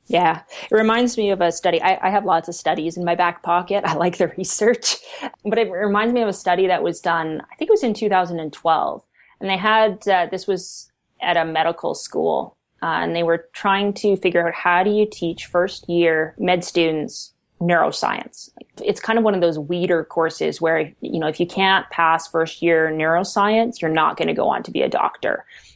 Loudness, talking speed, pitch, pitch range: -20 LUFS, 215 wpm, 175 Hz, 165-200 Hz